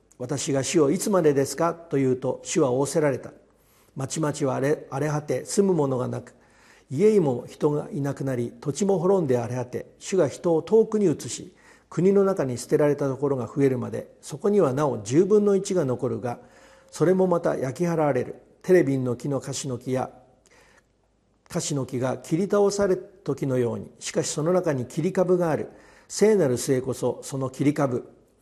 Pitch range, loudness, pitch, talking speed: 130-175 Hz, -24 LUFS, 145 Hz, 335 characters per minute